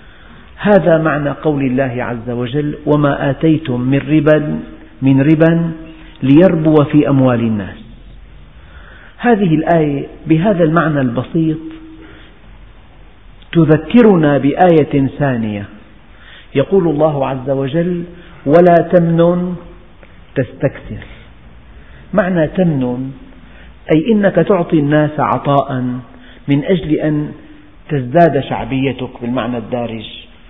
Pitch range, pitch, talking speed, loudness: 120-160 Hz, 140 Hz, 90 wpm, -13 LUFS